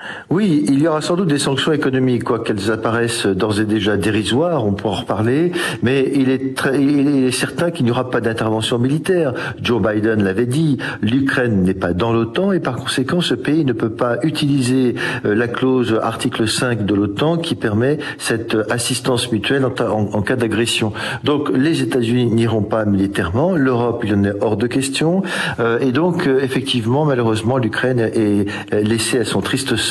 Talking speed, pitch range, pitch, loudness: 180 wpm, 110-135 Hz, 120 Hz, -17 LUFS